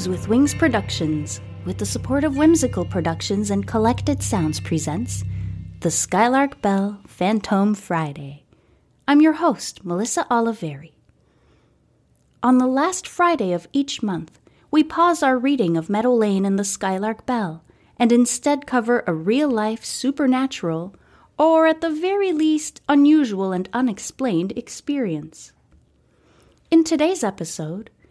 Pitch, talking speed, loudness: 220 Hz, 130 wpm, -20 LUFS